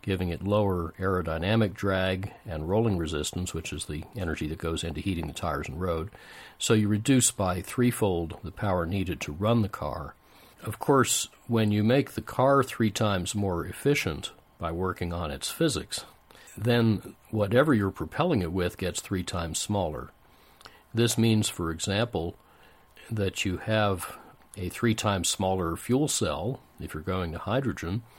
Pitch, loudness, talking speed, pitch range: 95 Hz, -28 LUFS, 160 wpm, 85-110 Hz